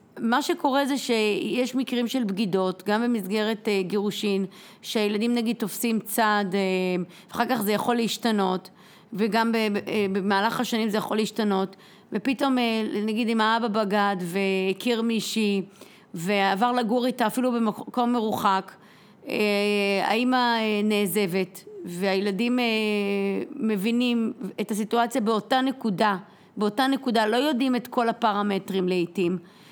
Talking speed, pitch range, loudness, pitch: 125 wpm, 200-235 Hz, -25 LUFS, 215 Hz